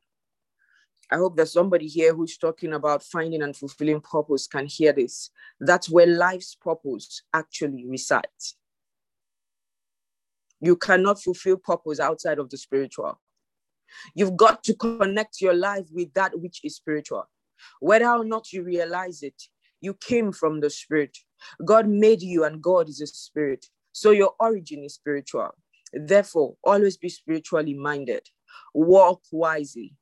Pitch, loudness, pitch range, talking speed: 170 Hz, -23 LUFS, 150-195 Hz, 140 wpm